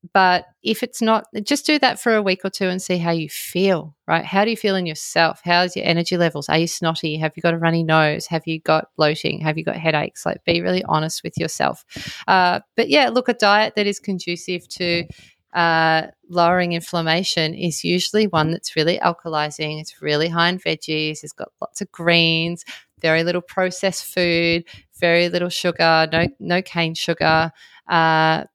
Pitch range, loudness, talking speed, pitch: 160-185 Hz, -19 LUFS, 195 wpm, 170 Hz